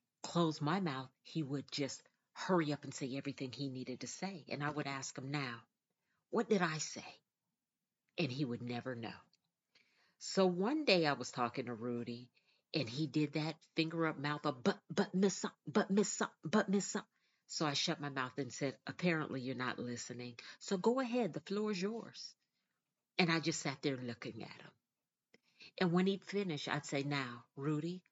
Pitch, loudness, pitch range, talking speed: 150 Hz, -38 LUFS, 135-185 Hz, 190 wpm